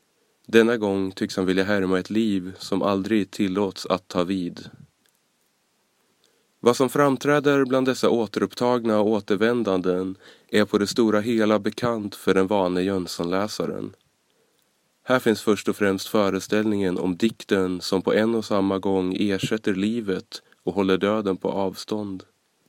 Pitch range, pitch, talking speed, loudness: 95-110 Hz, 105 Hz, 140 wpm, -23 LUFS